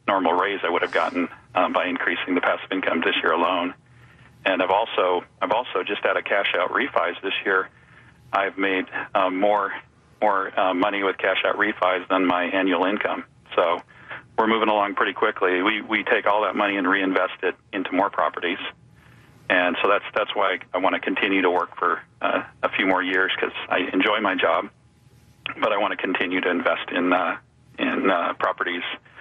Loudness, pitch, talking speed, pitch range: -22 LUFS, 95 Hz, 195 wpm, 90-100 Hz